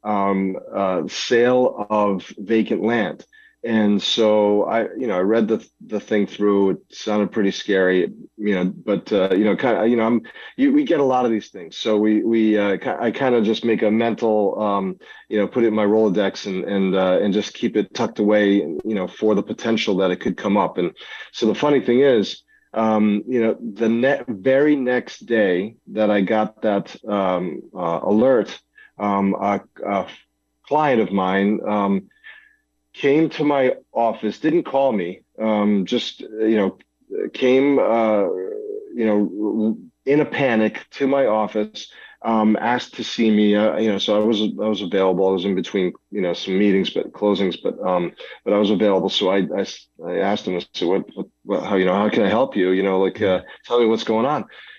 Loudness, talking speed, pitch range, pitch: -20 LUFS, 205 wpm, 100-115 Hz, 110 Hz